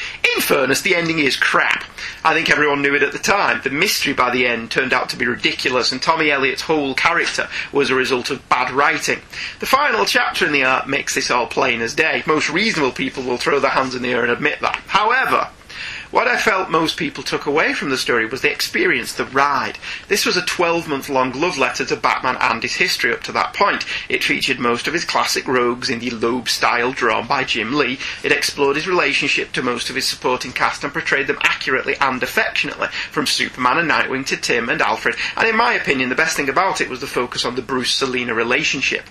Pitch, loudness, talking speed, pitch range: 135 Hz, -17 LUFS, 225 wpm, 125-160 Hz